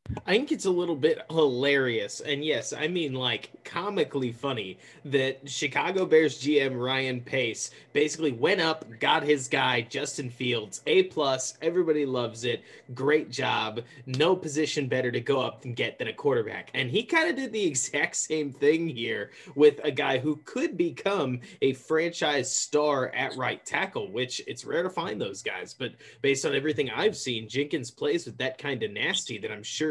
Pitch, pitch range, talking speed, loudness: 150 Hz, 130-160 Hz, 185 wpm, -27 LUFS